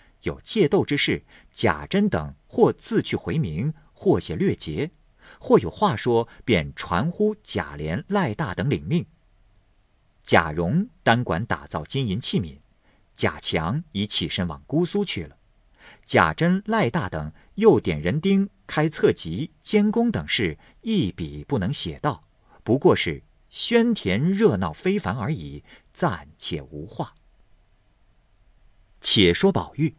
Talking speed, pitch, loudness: 185 characters per minute, 120 Hz, -23 LUFS